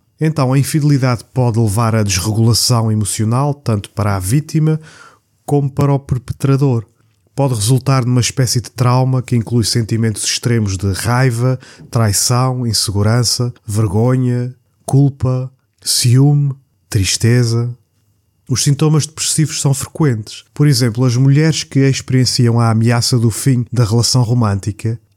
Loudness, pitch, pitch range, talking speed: -14 LUFS, 125 Hz, 115-135 Hz, 125 wpm